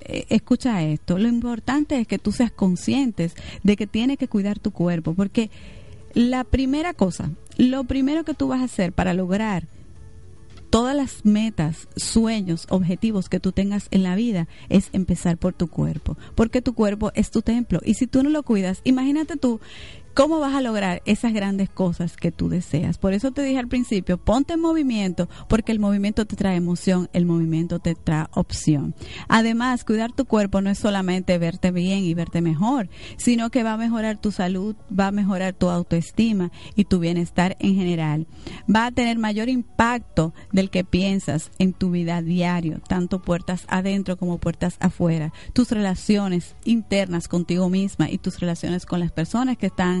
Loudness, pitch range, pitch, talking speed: -22 LUFS, 175-230 Hz, 195 Hz, 180 wpm